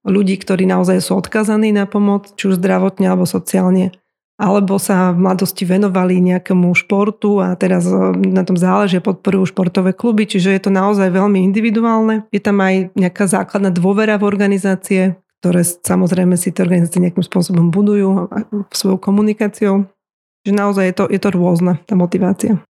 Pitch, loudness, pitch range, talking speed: 190 Hz, -14 LUFS, 185-205 Hz, 160 wpm